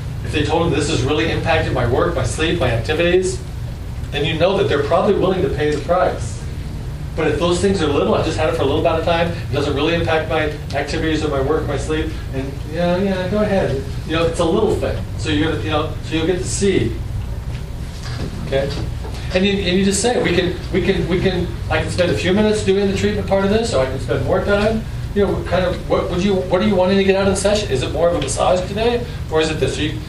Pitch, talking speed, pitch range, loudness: 170 Hz, 265 wpm, 135-190 Hz, -18 LUFS